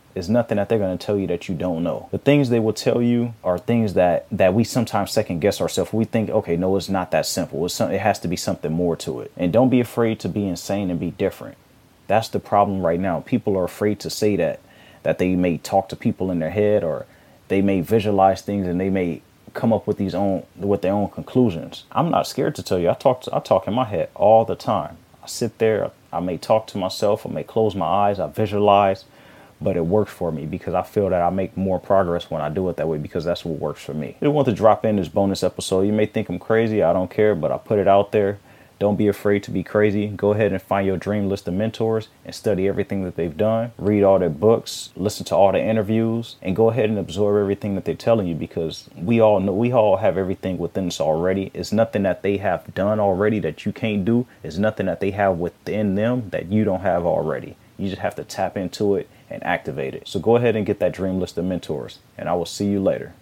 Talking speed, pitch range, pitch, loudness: 260 wpm, 95-110 Hz, 100 Hz, -21 LUFS